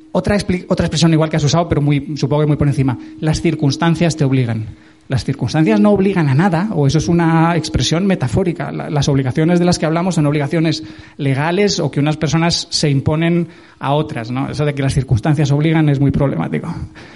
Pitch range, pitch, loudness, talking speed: 140-170 Hz, 155 Hz, -15 LUFS, 205 wpm